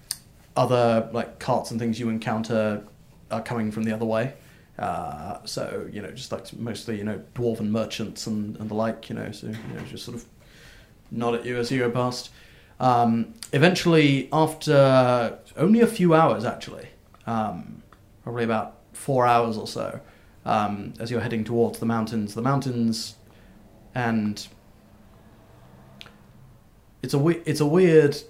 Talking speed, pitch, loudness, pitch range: 155 wpm, 115 Hz, -24 LUFS, 110-125 Hz